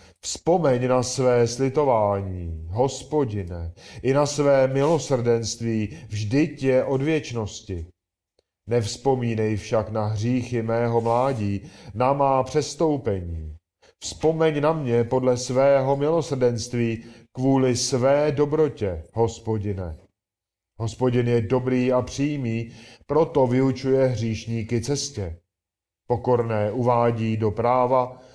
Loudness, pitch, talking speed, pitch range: -23 LUFS, 120 Hz, 95 wpm, 110-135 Hz